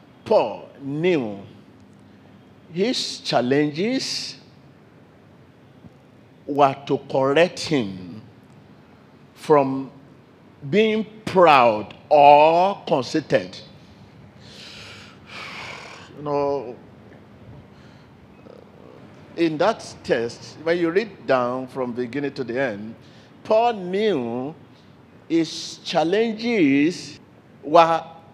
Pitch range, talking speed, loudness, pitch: 135-175 Hz, 70 wpm, -21 LUFS, 145 Hz